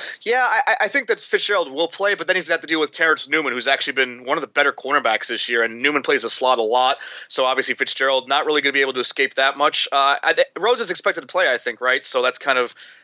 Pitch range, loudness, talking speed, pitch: 130-170 Hz, -19 LUFS, 290 wpm, 140 Hz